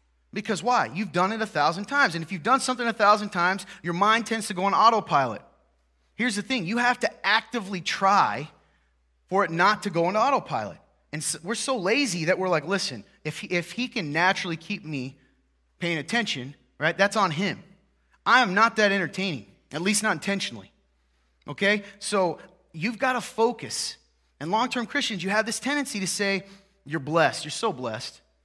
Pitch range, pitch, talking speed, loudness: 165-220 Hz, 195 Hz, 190 wpm, -25 LUFS